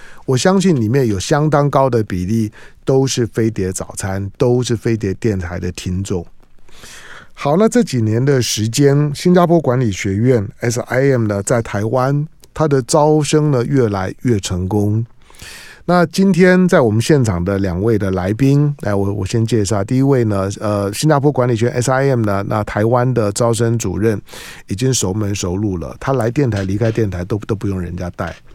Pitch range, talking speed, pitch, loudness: 100-135 Hz, 265 characters per minute, 115 Hz, -16 LUFS